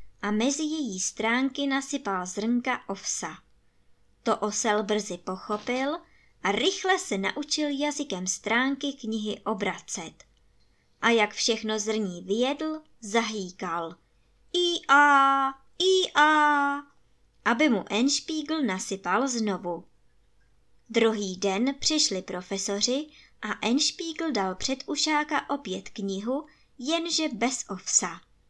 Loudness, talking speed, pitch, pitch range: -26 LUFS, 100 wpm, 245 Hz, 205-295 Hz